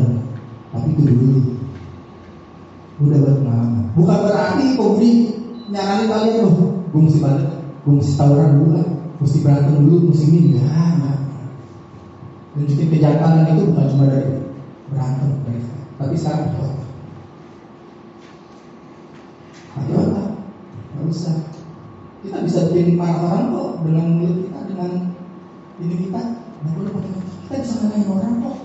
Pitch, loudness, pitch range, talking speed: 160 Hz, -17 LUFS, 140-185 Hz, 130 wpm